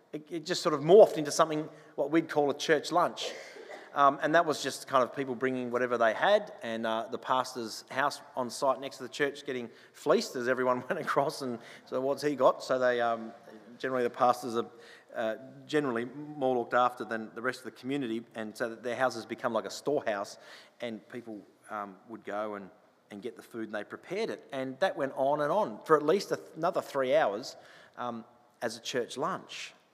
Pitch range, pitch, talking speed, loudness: 115-145 Hz, 130 Hz, 210 wpm, -30 LUFS